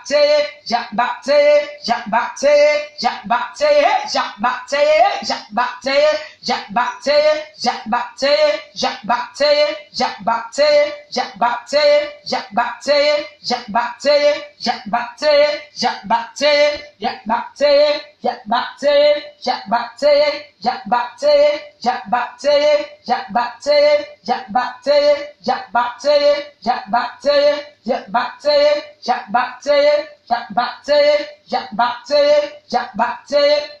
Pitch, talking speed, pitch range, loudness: 285 Hz, 65 wpm, 240-295 Hz, -17 LUFS